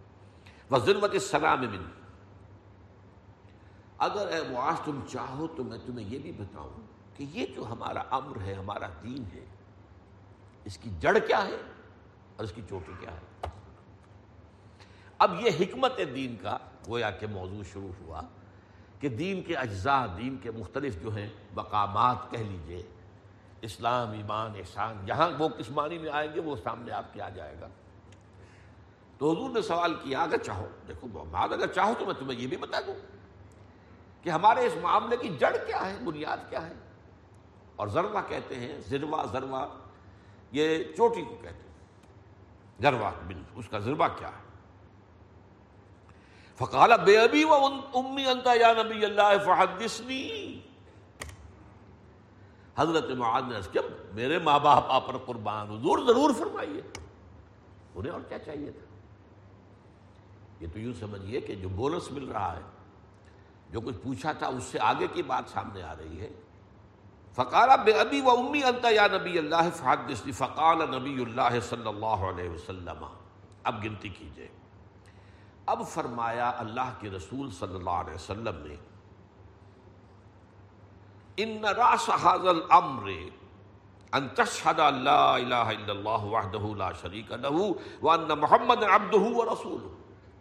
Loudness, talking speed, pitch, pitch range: -28 LUFS, 140 wpm, 105 Hz, 95-130 Hz